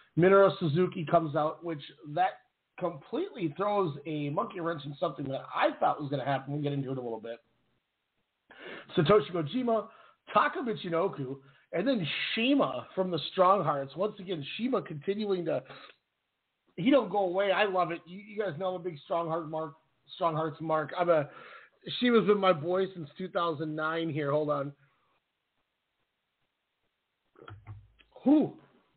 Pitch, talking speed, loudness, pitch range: 170 Hz, 155 wpm, -30 LUFS, 150-195 Hz